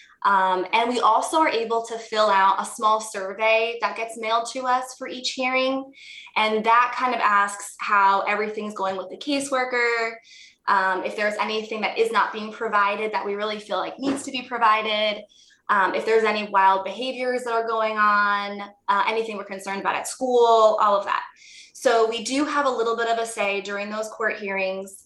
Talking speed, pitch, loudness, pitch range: 200 wpm, 220 Hz, -22 LUFS, 200-240 Hz